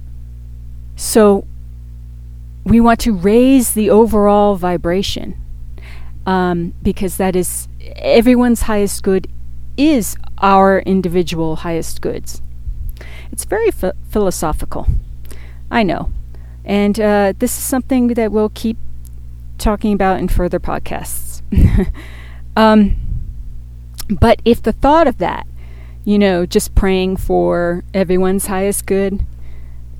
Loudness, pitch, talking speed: -15 LUFS, 170 Hz, 110 wpm